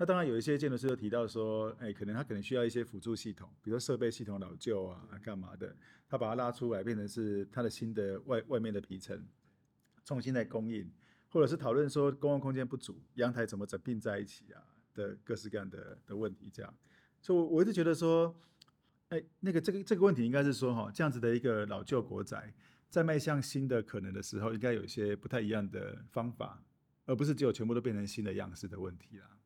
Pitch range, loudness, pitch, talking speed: 105-140 Hz, -36 LUFS, 120 Hz, 345 characters per minute